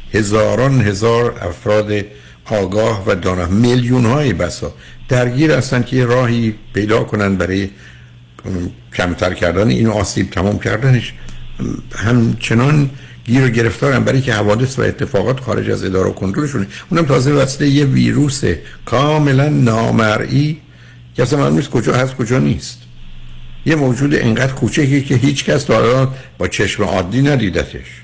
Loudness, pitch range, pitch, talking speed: -15 LUFS, 95-130 Hz, 115 Hz, 135 wpm